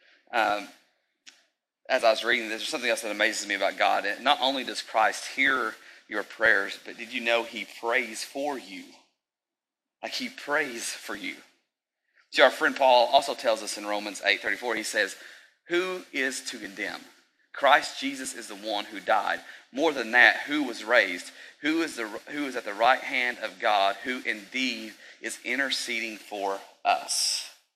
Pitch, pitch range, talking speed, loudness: 120 Hz, 110-175 Hz, 175 wpm, -26 LUFS